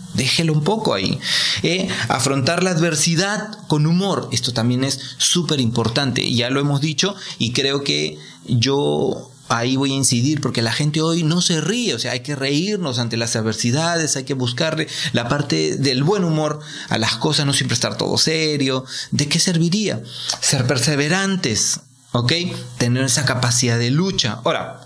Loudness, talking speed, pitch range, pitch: -18 LUFS, 170 wpm, 120-165 Hz, 140 Hz